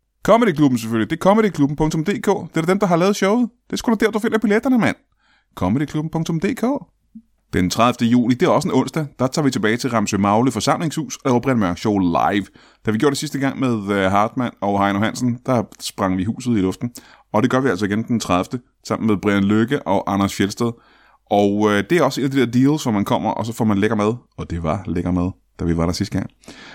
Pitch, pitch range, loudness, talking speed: 120 Hz, 105-155 Hz, -19 LUFS, 235 wpm